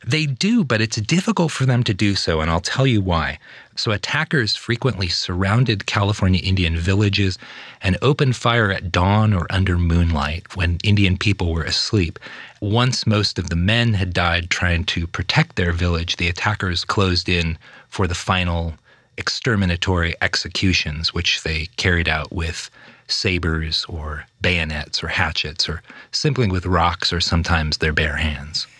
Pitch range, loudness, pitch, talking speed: 85-105 Hz, -19 LUFS, 90 Hz, 155 wpm